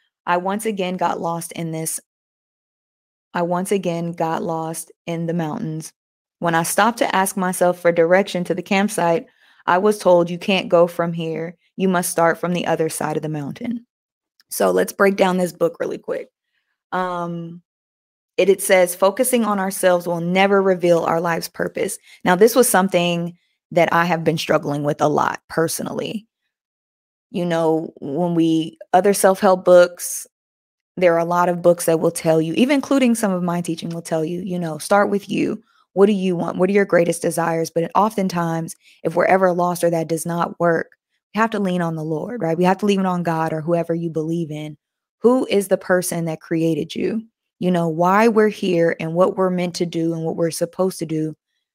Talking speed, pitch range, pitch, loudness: 200 wpm, 165-190 Hz, 175 Hz, -19 LUFS